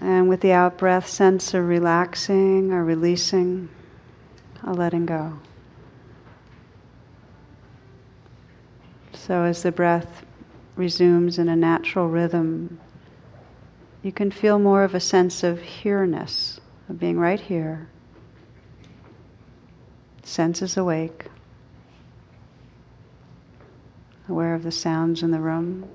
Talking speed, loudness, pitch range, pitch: 100 wpm, -22 LUFS, 155-185 Hz, 170 Hz